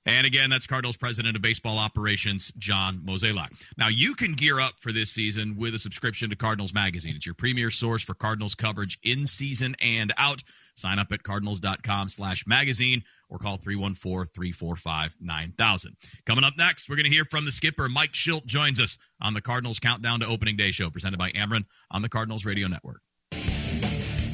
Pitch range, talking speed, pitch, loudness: 100-125 Hz, 180 wpm, 110 Hz, -25 LUFS